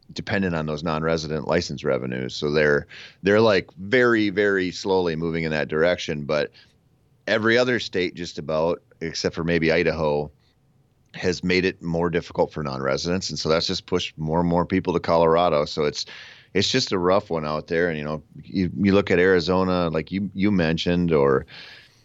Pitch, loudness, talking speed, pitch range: 85 Hz, -22 LUFS, 180 wpm, 80-95 Hz